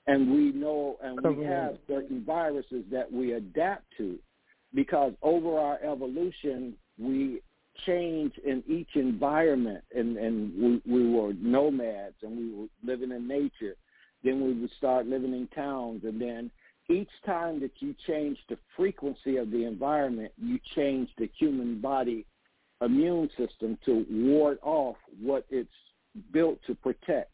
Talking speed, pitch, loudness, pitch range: 145 wpm, 140 Hz, -30 LUFS, 120-160 Hz